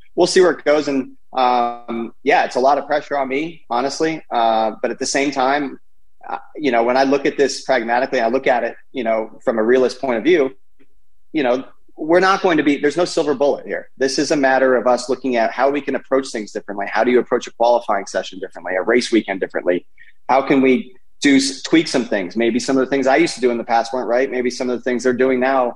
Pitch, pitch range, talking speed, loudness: 130 Hz, 120-140 Hz, 255 wpm, -18 LUFS